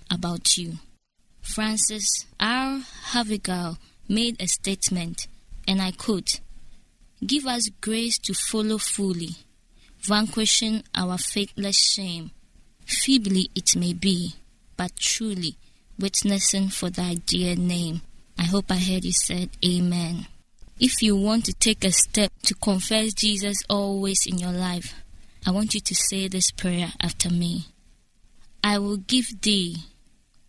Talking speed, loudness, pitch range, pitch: 130 wpm, -23 LUFS, 180-215 Hz, 195 Hz